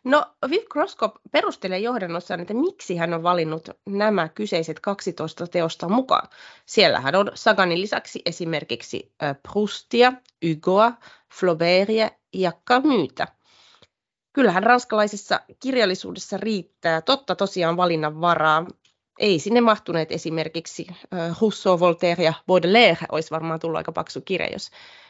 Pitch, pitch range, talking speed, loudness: 185 Hz, 165-220 Hz, 115 wpm, -22 LUFS